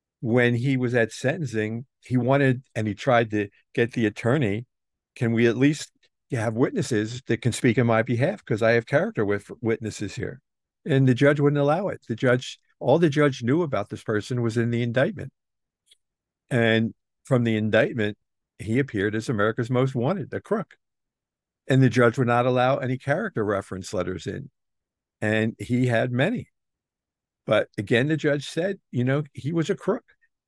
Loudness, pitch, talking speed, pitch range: -24 LUFS, 120 Hz, 175 wpm, 110-135 Hz